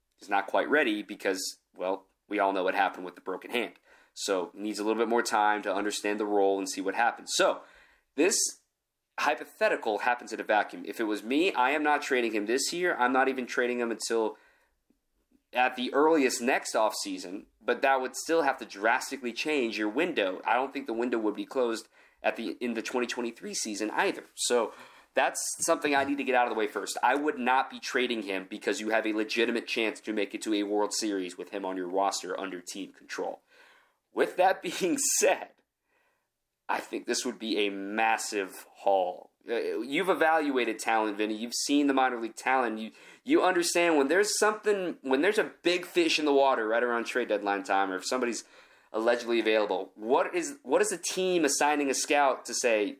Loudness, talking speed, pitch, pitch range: -28 LUFS, 205 wpm, 125 Hz, 110-160 Hz